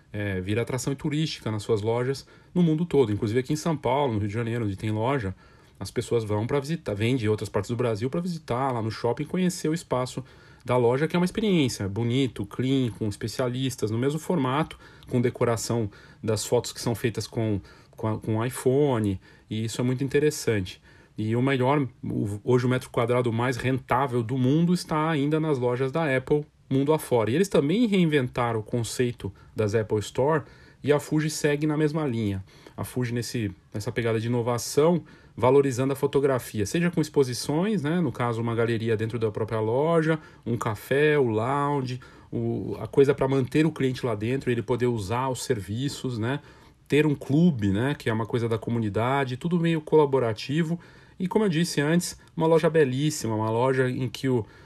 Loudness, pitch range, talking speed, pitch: -26 LUFS, 115-150 Hz, 195 wpm, 125 Hz